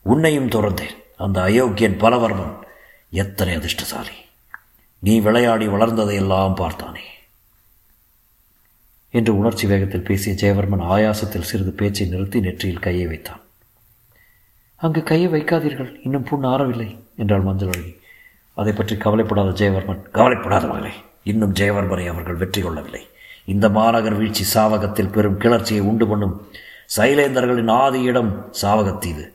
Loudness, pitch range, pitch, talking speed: -19 LUFS, 95-115 Hz, 105 Hz, 110 wpm